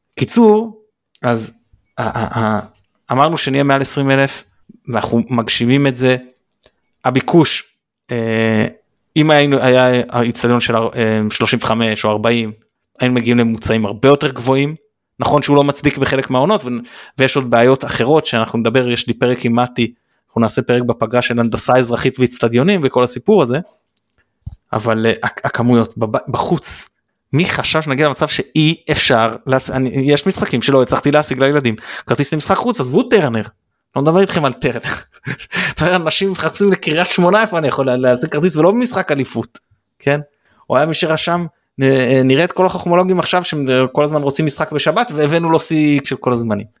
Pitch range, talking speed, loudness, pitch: 115-155 Hz, 160 wpm, -14 LUFS, 130 Hz